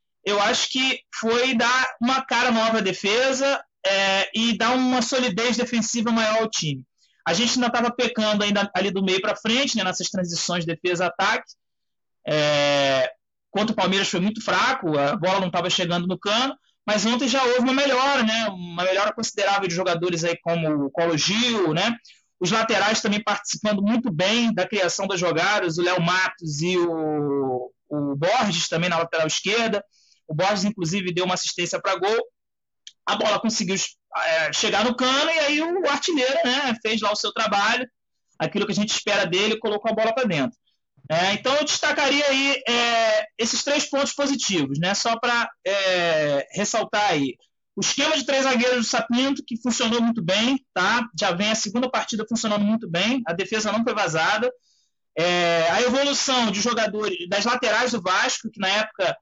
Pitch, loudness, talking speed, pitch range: 210 Hz, -22 LUFS, 180 wpm, 180-240 Hz